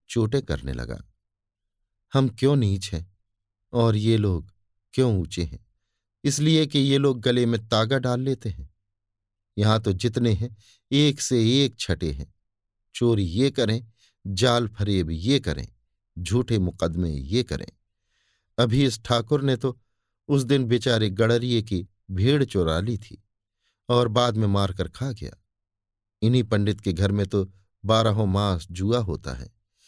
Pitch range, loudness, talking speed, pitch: 100-120 Hz, -24 LUFS, 150 wpm, 105 Hz